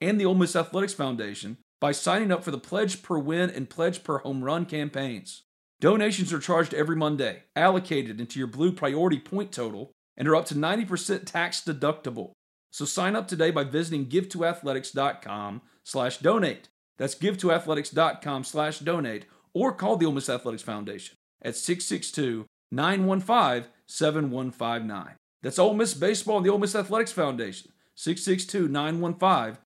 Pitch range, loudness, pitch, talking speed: 135-185 Hz, -27 LUFS, 160 Hz, 150 wpm